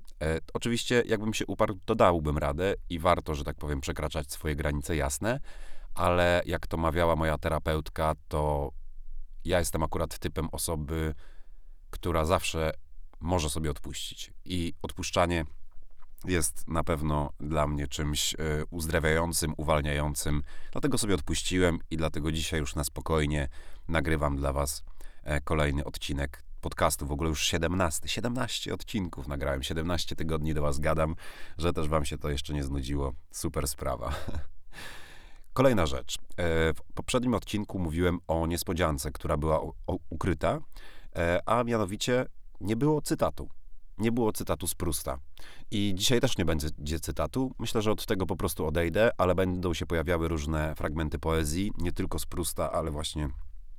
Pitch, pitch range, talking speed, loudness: 80 Hz, 75-90 Hz, 140 wpm, -30 LUFS